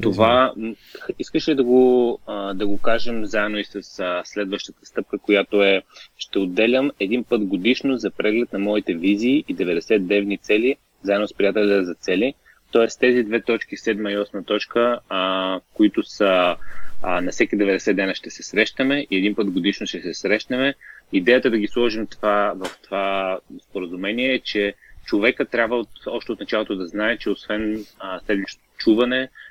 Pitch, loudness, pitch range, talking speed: 110 Hz, -21 LUFS, 100-125 Hz, 160 wpm